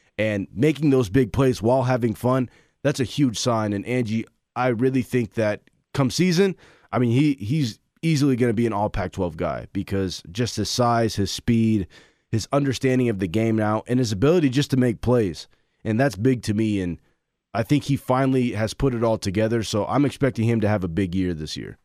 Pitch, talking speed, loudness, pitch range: 120 Hz, 215 wpm, -23 LUFS, 105-130 Hz